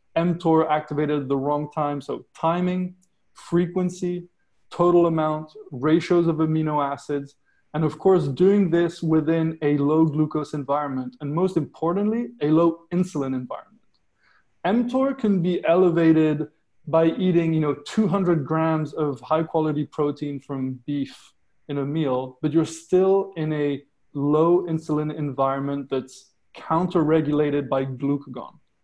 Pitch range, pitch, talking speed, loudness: 145-170 Hz, 155 Hz, 130 wpm, -23 LUFS